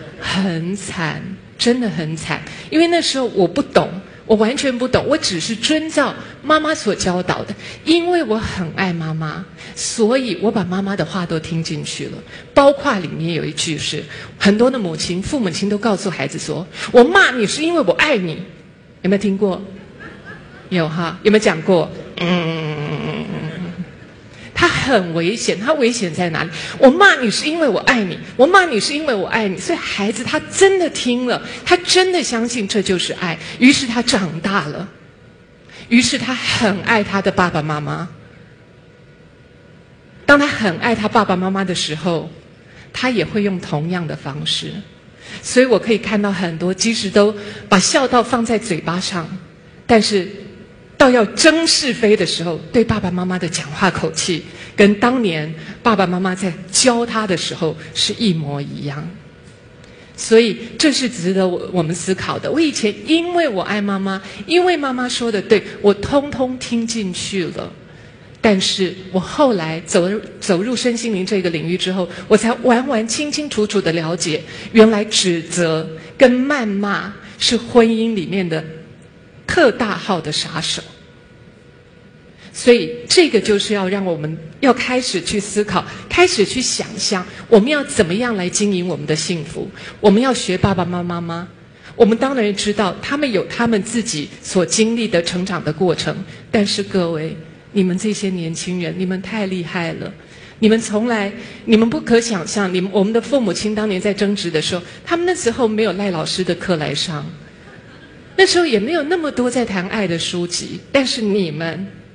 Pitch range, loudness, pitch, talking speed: 175-235 Hz, -17 LUFS, 200 Hz, 245 characters per minute